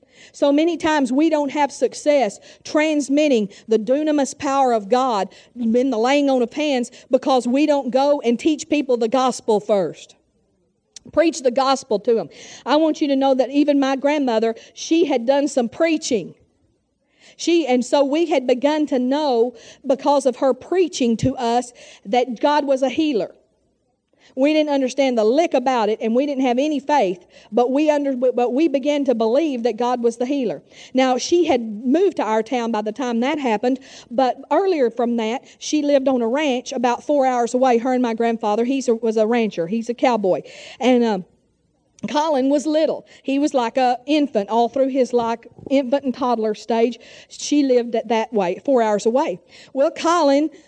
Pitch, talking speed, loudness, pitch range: 260 Hz, 185 wpm, -19 LUFS, 235-290 Hz